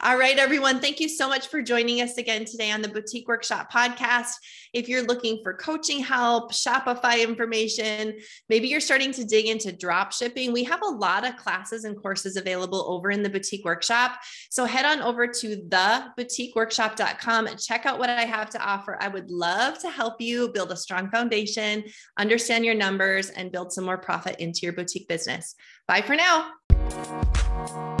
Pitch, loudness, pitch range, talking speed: 225 Hz, -24 LUFS, 195-245 Hz, 185 wpm